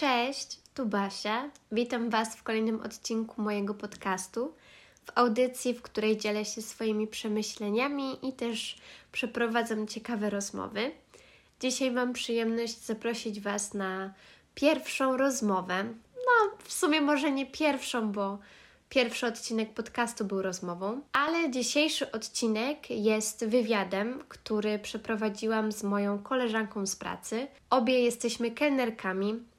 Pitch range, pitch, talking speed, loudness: 215-255 Hz, 230 Hz, 120 wpm, -31 LUFS